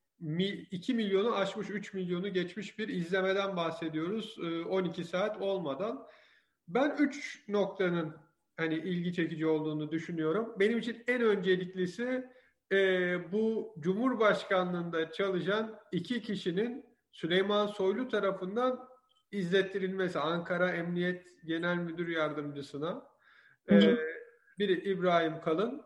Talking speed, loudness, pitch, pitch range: 95 wpm, -32 LUFS, 190 Hz, 170-215 Hz